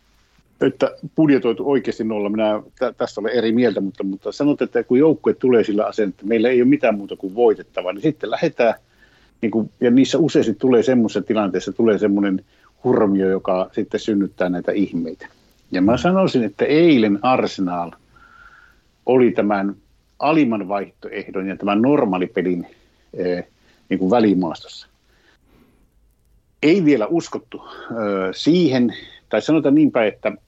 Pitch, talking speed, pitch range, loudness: 110 Hz, 135 wpm, 95-125 Hz, -19 LUFS